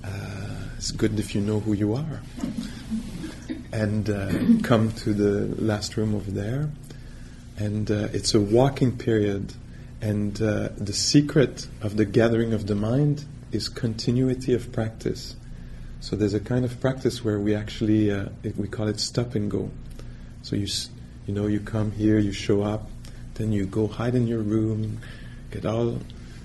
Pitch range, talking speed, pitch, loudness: 105-120 Hz, 165 wpm, 110 Hz, -25 LUFS